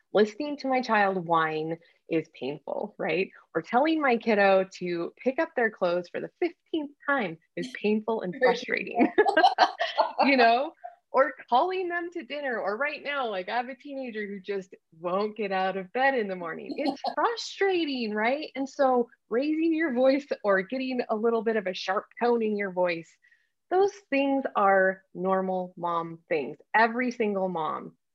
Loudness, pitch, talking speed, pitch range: -27 LUFS, 240 Hz, 170 wpm, 190-285 Hz